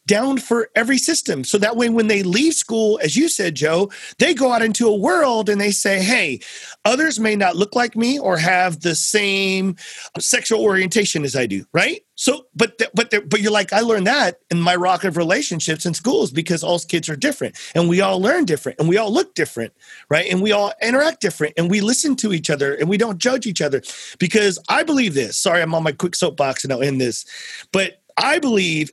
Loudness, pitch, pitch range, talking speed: -18 LUFS, 205 Hz, 175-230 Hz, 225 wpm